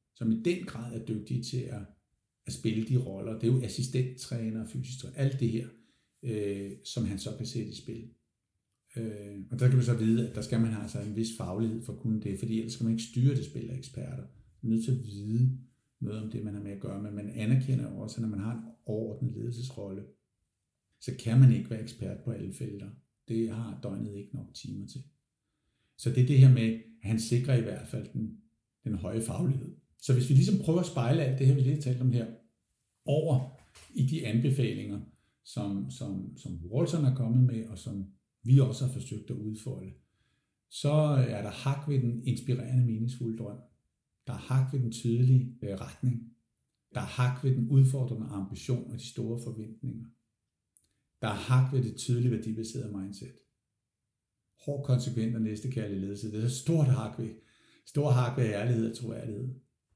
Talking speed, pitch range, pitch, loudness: 205 wpm, 110-130 Hz, 120 Hz, -31 LUFS